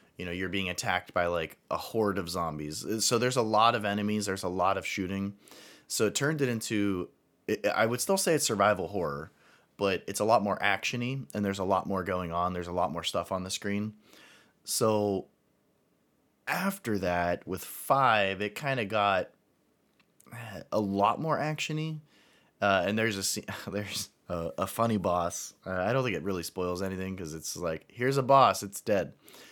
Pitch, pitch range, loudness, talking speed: 100 Hz, 95-115 Hz, -30 LUFS, 190 wpm